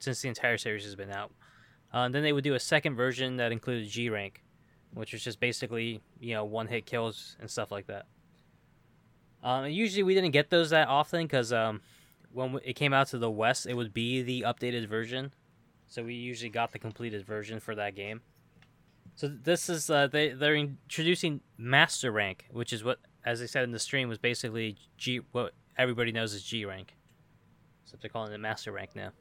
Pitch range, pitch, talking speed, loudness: 115-140 Hz, 125 Hz, 205 wpm, -31 LUFS